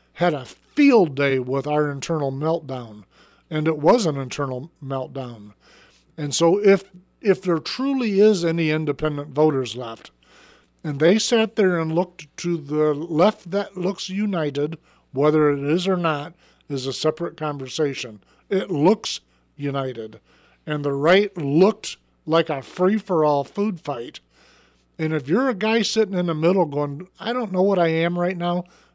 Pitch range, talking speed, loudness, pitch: 145-185 Hz, 160 wpm, -22 LUFS, 160 Hz